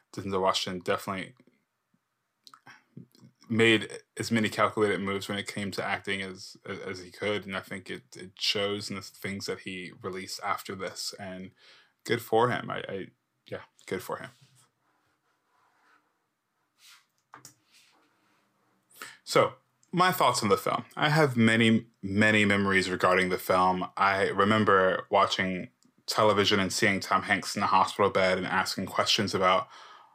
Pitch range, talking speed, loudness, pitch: 95-110 Hz, 140 wpm, -27 LUFS, 100 Hz